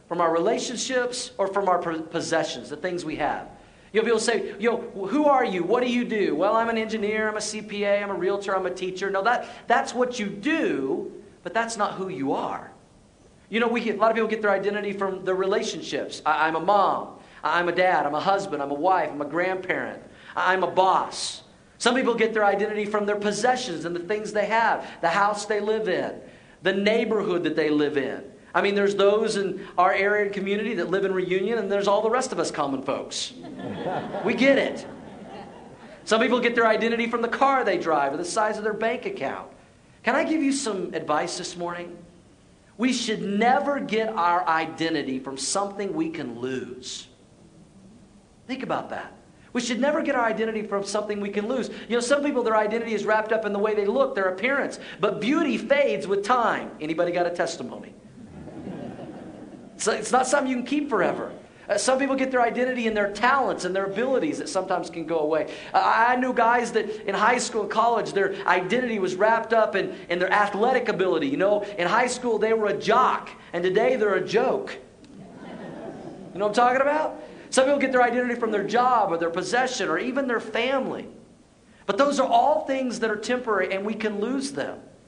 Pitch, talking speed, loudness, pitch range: 210 Hz, 210 wpm, -24 LUFS, 185-240 Hz